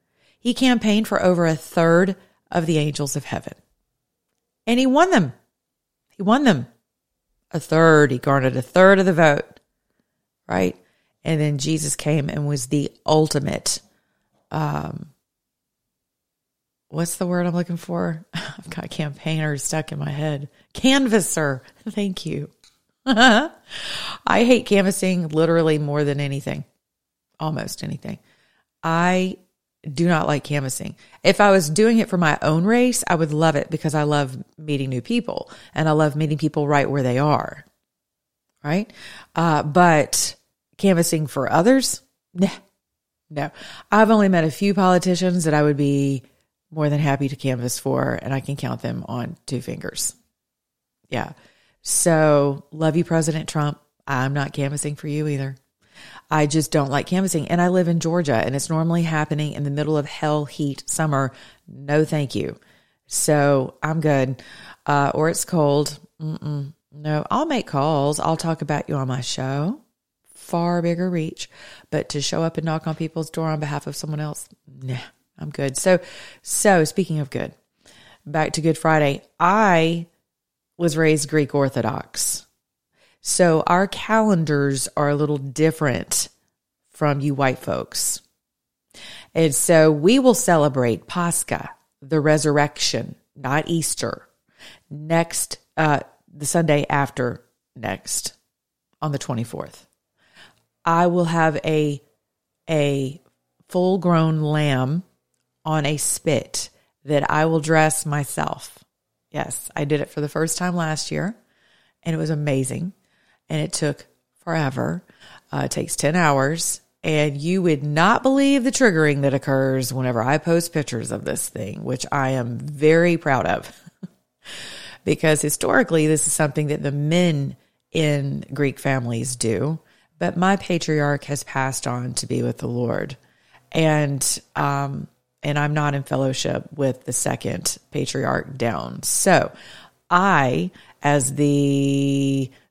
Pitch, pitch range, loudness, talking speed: 155 Hz, 140-170 Hz, -21 LUFS, 145 wpm